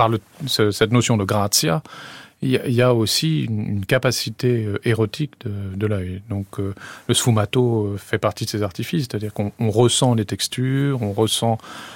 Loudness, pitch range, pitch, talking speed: -20 LUFS, 105-125 Hz, 110 Hz, 150 wpm